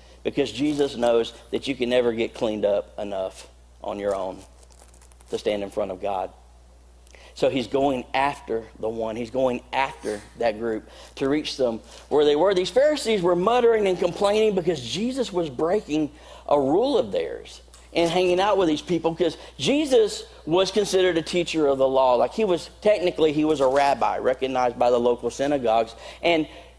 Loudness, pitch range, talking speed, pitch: -23 LUFS, 115-180 Hz, 180 wpm, 140 Hz